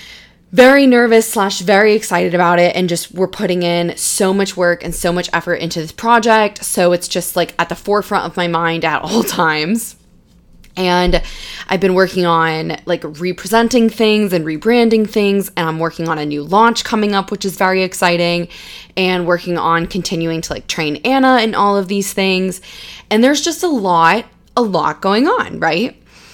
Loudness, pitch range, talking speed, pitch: -14 LUFS, 175-215 Hz, 185 wpm, 185 Hz